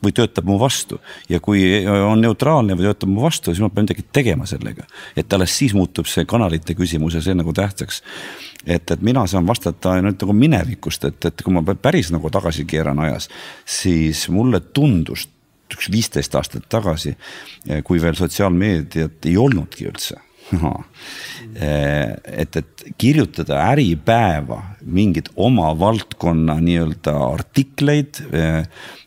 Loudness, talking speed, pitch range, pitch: -18 LUFS, 140 wpm, 80-110 Hz, 95 Hz